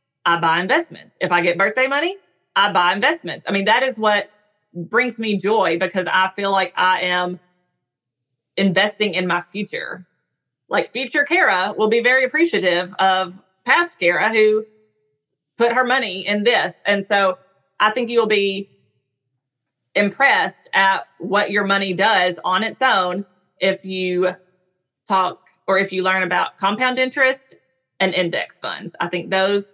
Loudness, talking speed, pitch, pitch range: -18 LUFS, 155 wpm, 195 Hz, 180-215 Hz